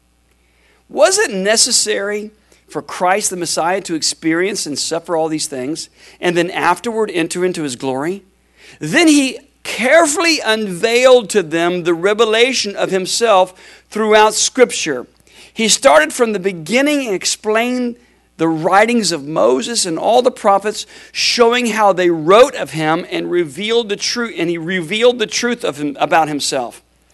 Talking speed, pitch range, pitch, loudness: 150 wpm, 170-235 Hz, 200 Hz, -14 LUFS